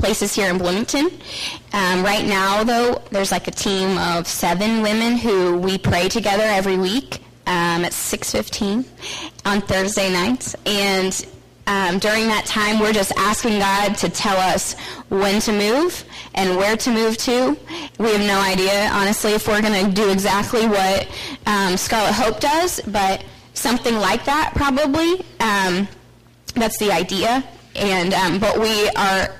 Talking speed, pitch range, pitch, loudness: 155 wpm, 190-225 Hz, 205 Hz, -18 LUFS